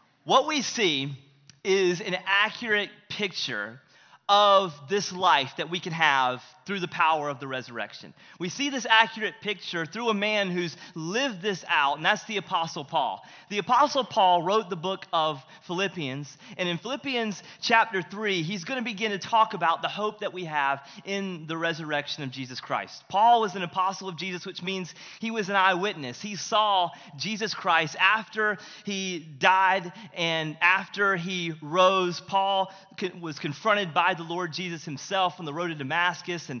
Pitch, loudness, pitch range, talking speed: 185 Hz, -26 LUFS, 165-205 Hz, 170 wpm